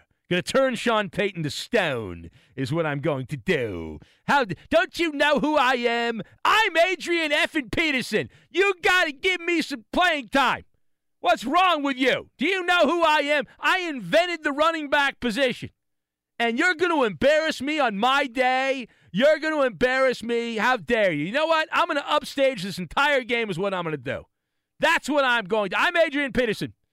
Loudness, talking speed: -23 LUFS, 185 wpm